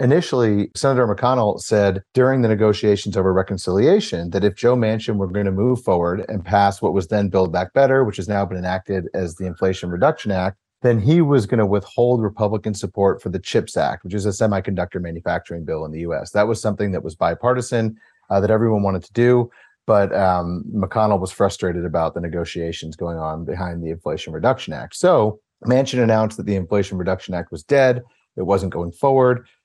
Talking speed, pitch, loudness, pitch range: 200 wpm, 100 Hz, -20 LUFS, 90-110 Hz